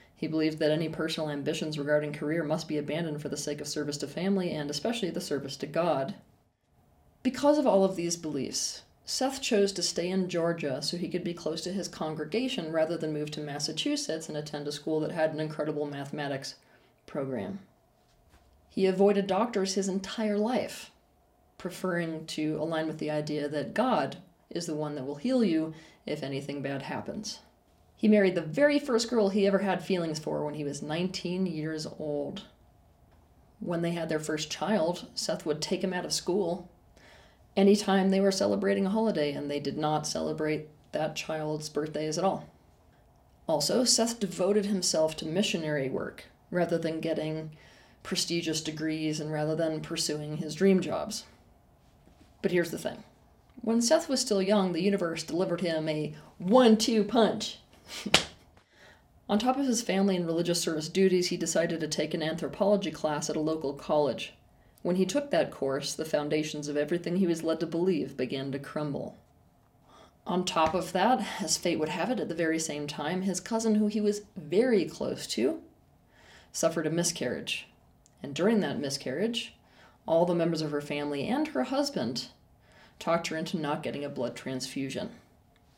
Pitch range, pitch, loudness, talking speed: 150-195 Hz, 165 Hz, -30 LUFS, 175 wpm